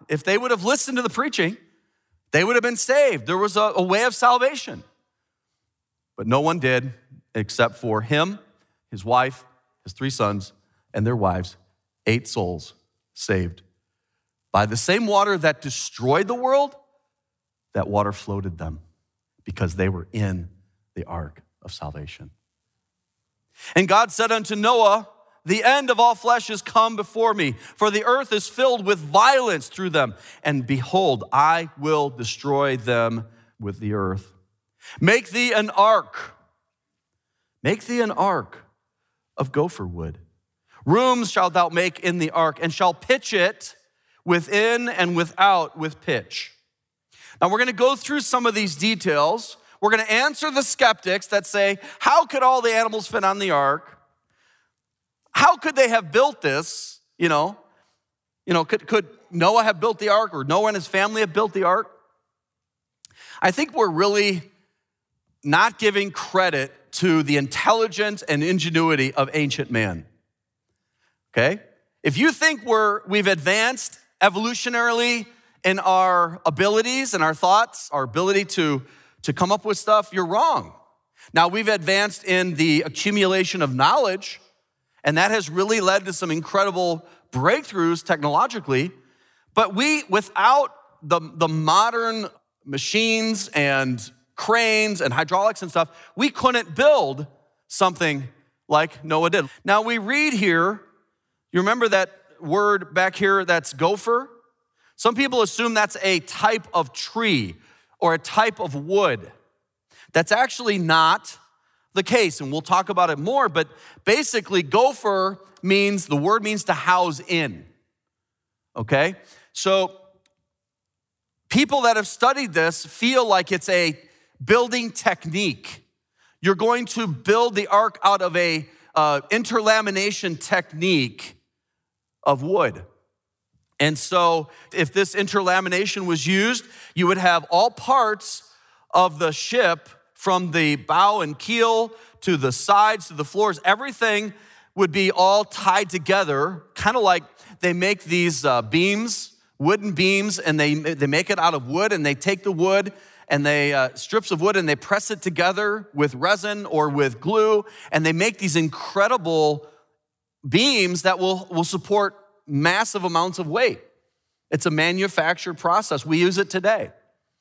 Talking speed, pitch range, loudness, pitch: 145 wpm, 150-215 Hz, -20 LUFS, 185 Hz